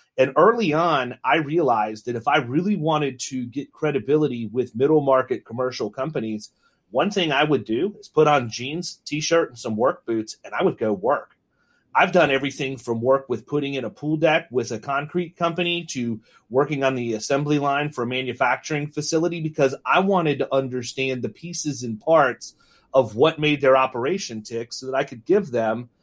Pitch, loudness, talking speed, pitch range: 135 Hz, -22 LUFS, 195 wpm, 125-155 Hz